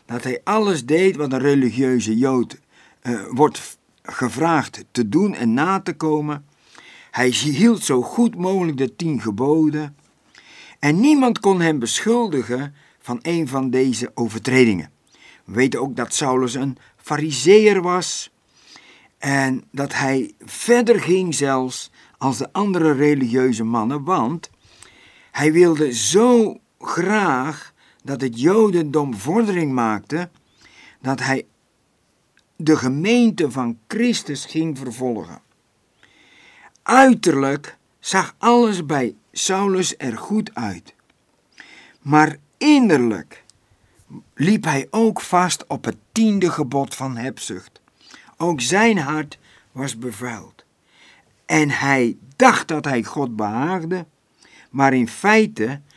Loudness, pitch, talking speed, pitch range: -19 LUFS, 150 Hz, 115 wpm, 130-185 Hz